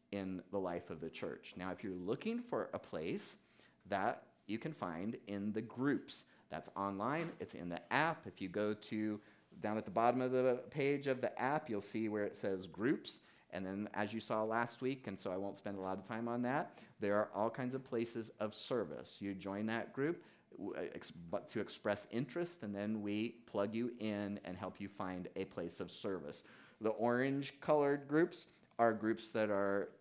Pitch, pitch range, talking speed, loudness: 105 Hz, 100-120 Hz, 210 wpm, -41 LUFS